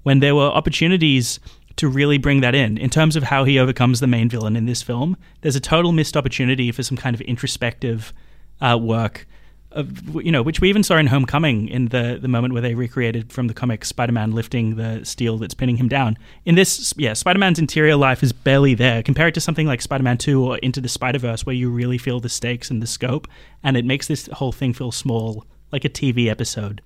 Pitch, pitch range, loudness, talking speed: 130 Hz, 120-145 Hz, -19 LUFS, 225 wpm